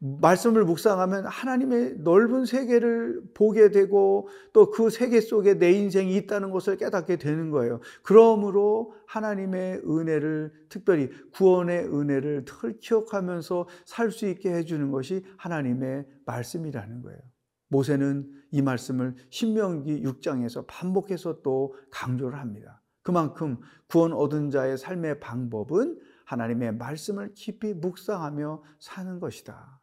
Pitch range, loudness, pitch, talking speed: 140-205 Hz, -25 LUFS, 170 Hz, 295 characters per minute